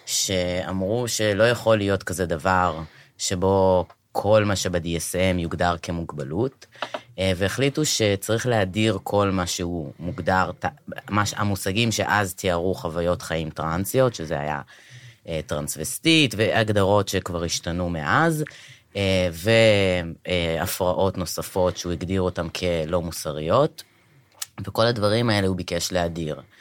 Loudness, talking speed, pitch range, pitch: -23 LUFS, 100 wpm, 85-110 Hz, 95 Hz